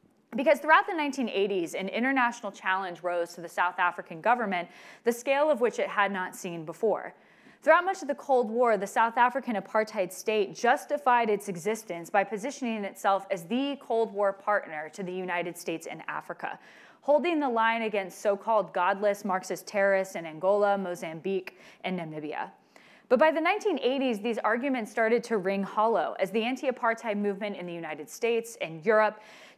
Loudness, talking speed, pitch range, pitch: -28 LUFS, 170 wpm, 190-245 Hz, 215 Hz